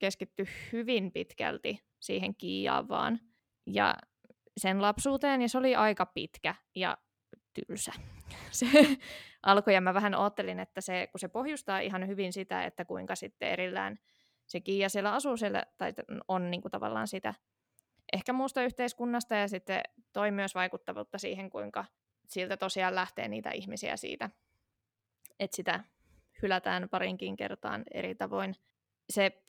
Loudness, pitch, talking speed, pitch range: -33 LUFS, 195 Hz, 140 wpm, 175-230 Hz